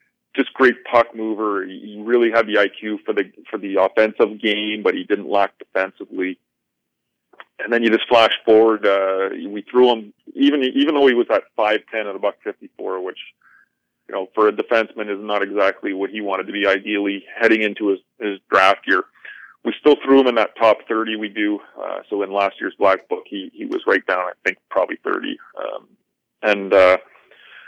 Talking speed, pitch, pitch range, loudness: 195 wpm, 110 Hz, 100-120 Hz, -19 LUFS